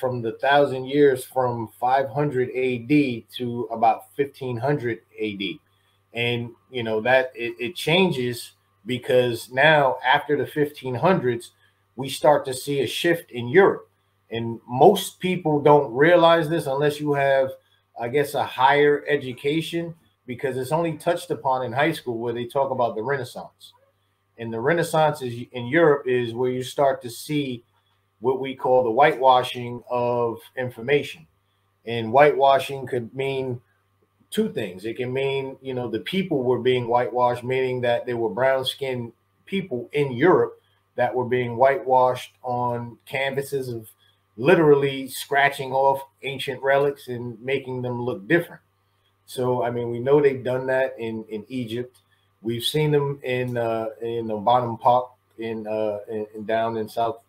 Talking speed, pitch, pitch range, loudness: 150 wpm, 125 Hz, 115-140 Hz, -23 LUFS